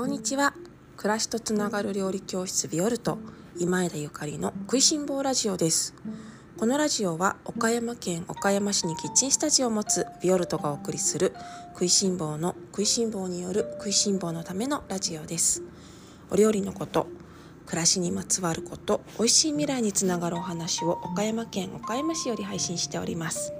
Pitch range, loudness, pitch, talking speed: 175-230 Hz, -26 LUFS, 195 Hz, 370 characters per minute